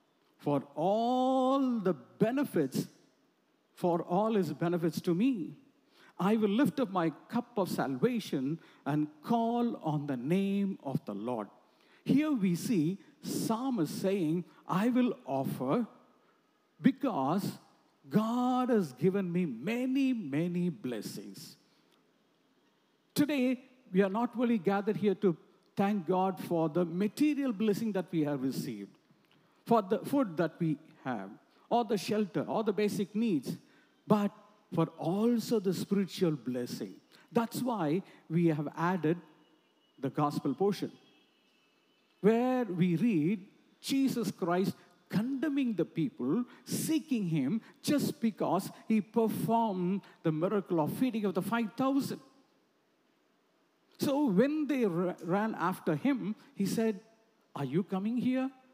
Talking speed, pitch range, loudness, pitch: 125 wpm, 175-240 Hz, -32 LUFS, 205 Hz